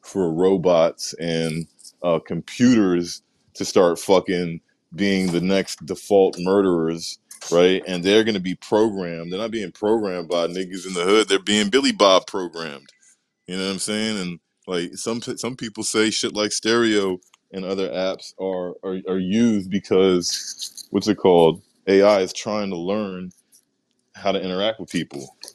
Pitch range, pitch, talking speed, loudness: 90-105 Hz, 95 Hz, 160 wpm, -21 LUFS